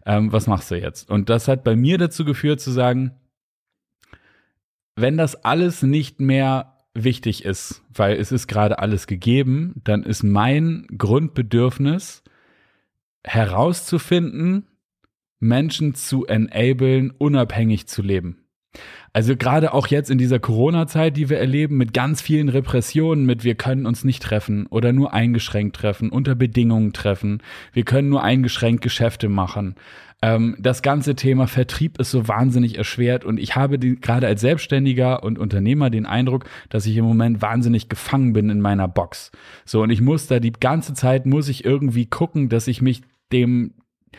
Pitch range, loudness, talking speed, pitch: 110-135 Hz, -19 LUFS, 160 wpm, 125 Hz